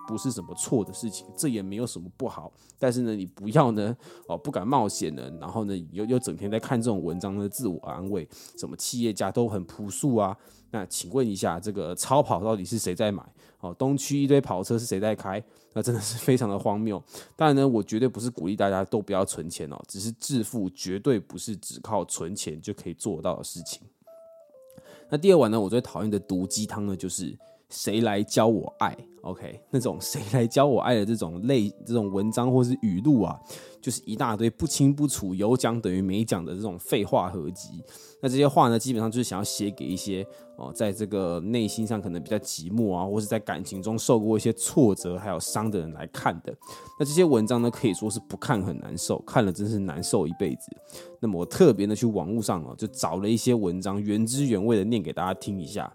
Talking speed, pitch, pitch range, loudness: 320 characters per minute, 110 Hz, 95-120 Hz, -27 LUFS